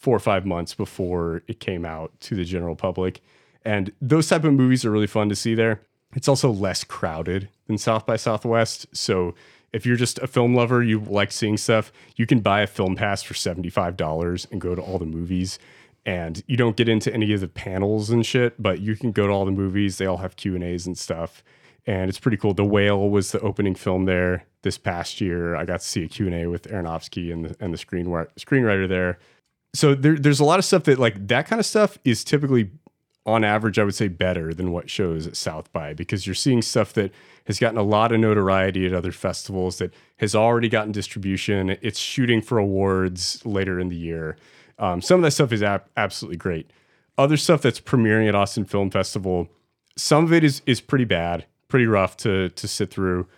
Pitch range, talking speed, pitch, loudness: 90-115 Hz, 220 wpm, 100 Hz, -22 LUFS